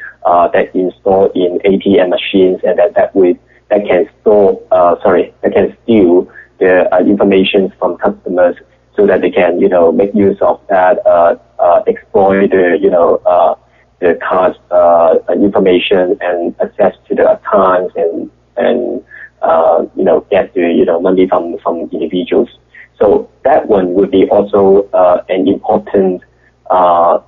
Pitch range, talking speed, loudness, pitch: 90-100 Hz, 160 wpm, -11 LUFS, 95 Hz